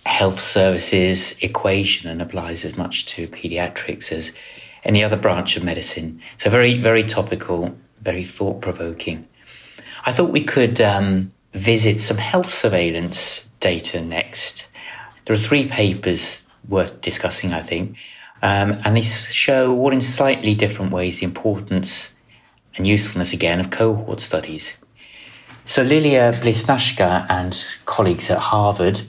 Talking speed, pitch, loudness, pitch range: 135 wpm, 95 Hz, -19 LUFS, 90-110 Hz